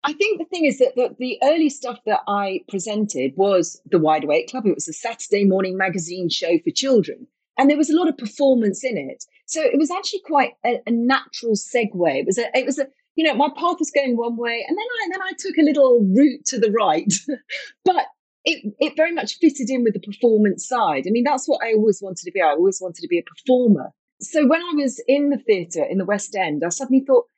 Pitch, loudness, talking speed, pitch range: 255 Hz, -20 LUFS, 250 wpm, 205-300 Hz